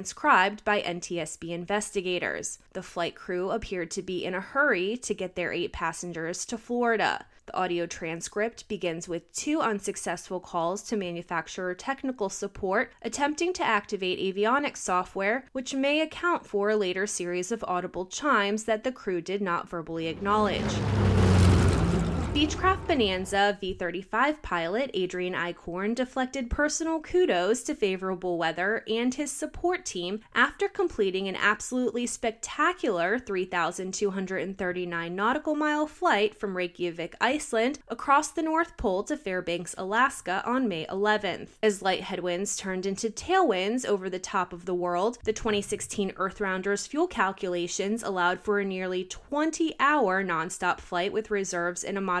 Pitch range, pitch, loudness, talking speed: 180-235 Hz, 200 Hz, -28 LUFS, 140 wpm